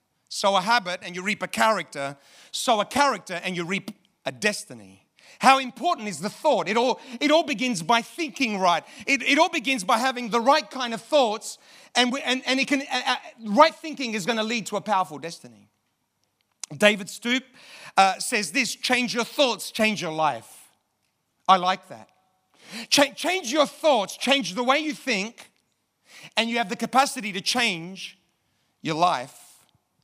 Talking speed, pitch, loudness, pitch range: 175 wpm, 225 Hz, -23 LUFS, 185-265 Hz